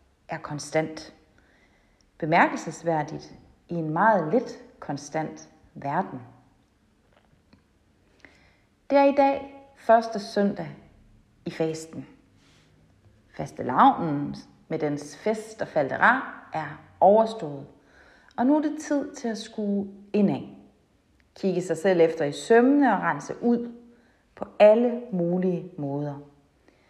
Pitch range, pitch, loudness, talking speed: 155-235 Hz, 190 Hz, -24 LUFS, 105 wpm